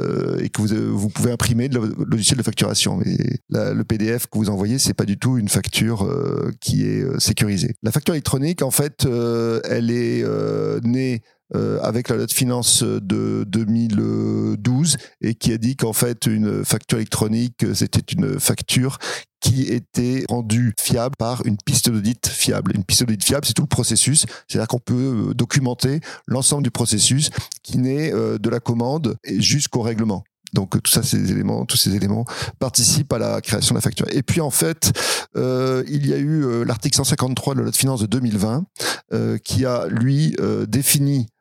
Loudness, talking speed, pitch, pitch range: -19 LUFS, 190 wpm, 120 Hz, 110-135 Hz